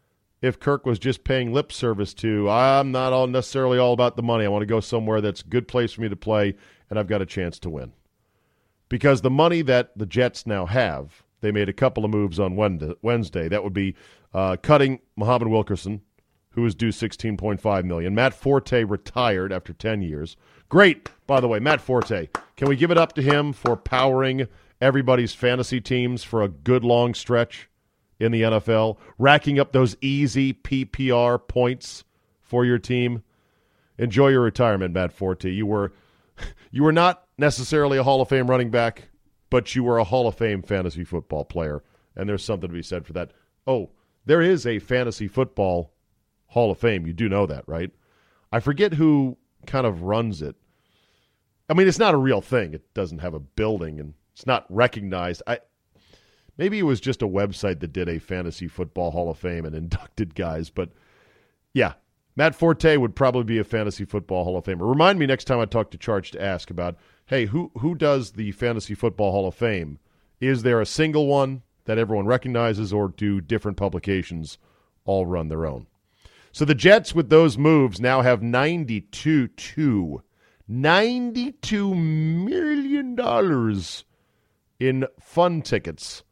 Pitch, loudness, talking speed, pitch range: 115 Hz, -22 LUFS, 185 wpm, 100-130 Hz